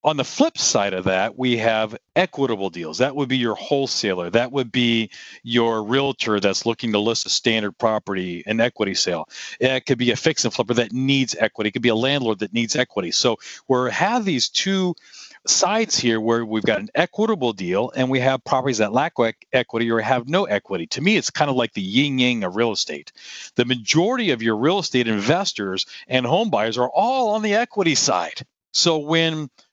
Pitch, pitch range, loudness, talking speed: 125 Hz, 110-145 Hz, -20 LUFS, 205 wpm